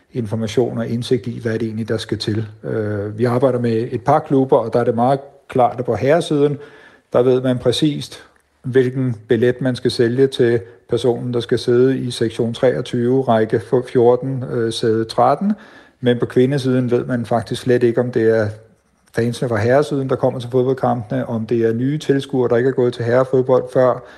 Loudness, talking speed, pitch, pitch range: -18 LUFS, 190 wpm, 125 Hz, 115-130 Hz